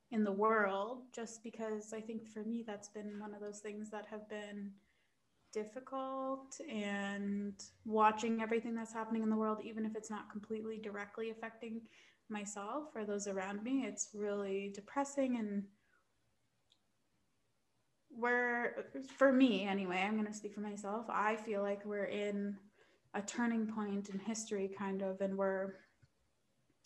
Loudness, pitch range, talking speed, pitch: -39 LUFS, 205-225 Hz, 150 wpm, 215 Hz